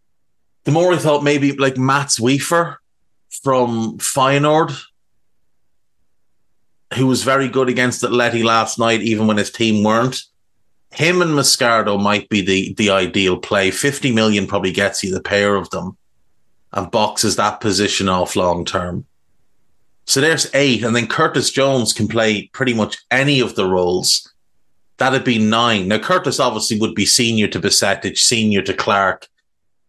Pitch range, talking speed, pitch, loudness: 100-135 Hz, 155 wpm, 115 Hz, -16 LUFS